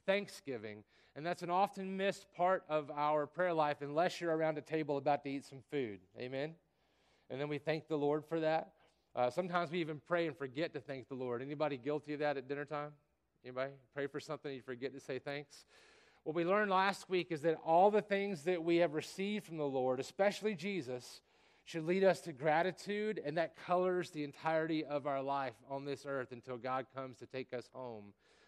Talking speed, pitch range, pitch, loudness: 210 wpm, 135-175 Hz, 150 Hz, -38 LUFS